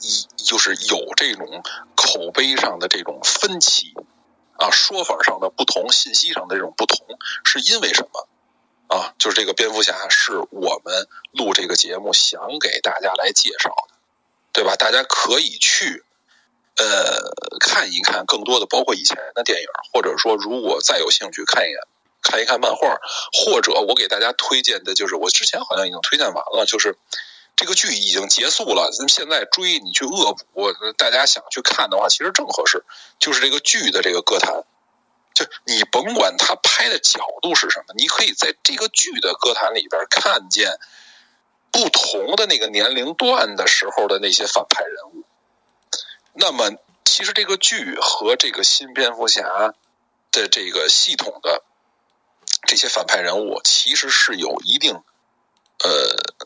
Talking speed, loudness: 250 characters per minute, -16 LUFS